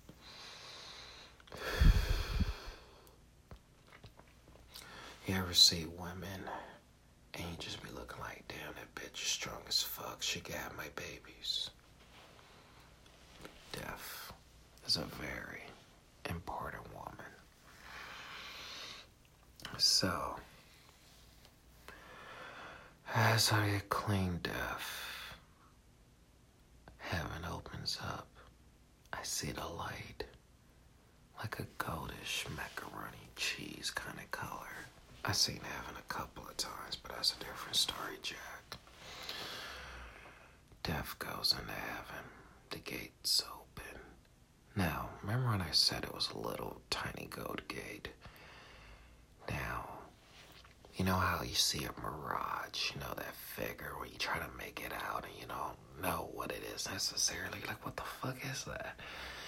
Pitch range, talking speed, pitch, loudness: 65-100 Hz, 115 wpm, 85 Hz, -38 LUFS